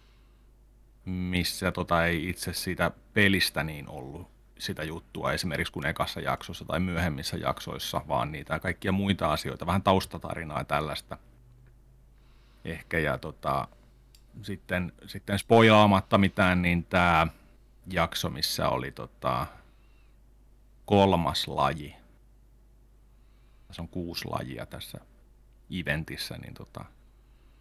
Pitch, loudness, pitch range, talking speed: 90 Hz, -28 LUFS, 80-105 Hz, 105 wpm